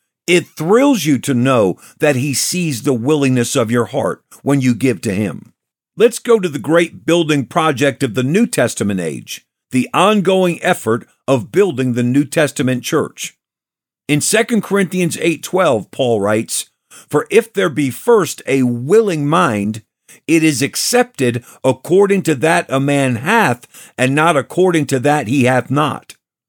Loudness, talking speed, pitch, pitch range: -15 LUFS, 160 wpm, 145 Hz, 130-175 Hz